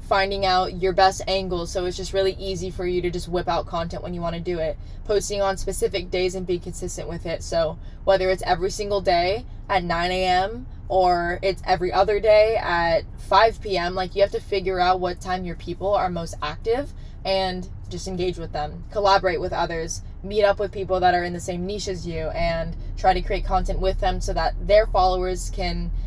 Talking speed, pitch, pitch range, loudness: 215 wpm, 185 Hz, 175-195 Hz, -23 LUFS